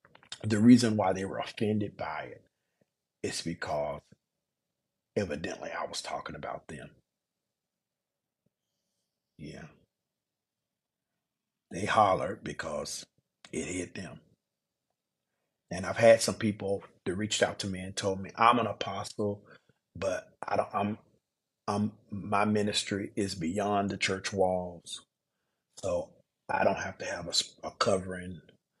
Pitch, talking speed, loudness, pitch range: 100 Hz, 125 wpm, -31 LUFS, 95-105 Hz